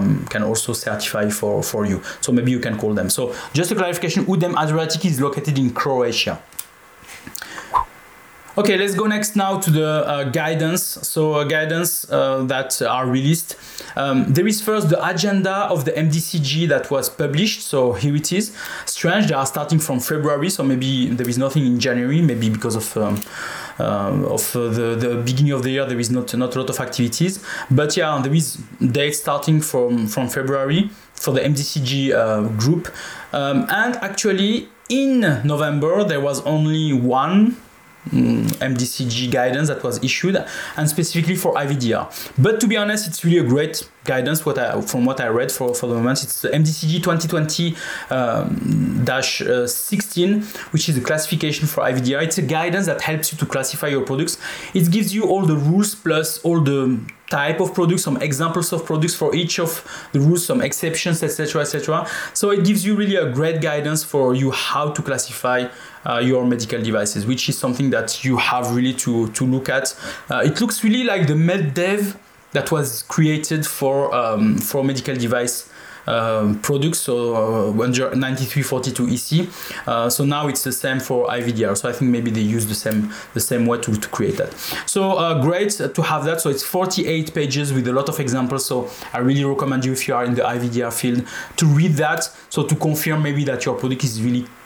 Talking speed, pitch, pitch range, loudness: 190 wpm, 145 Hz, 125-170 Hz, -19 LUFS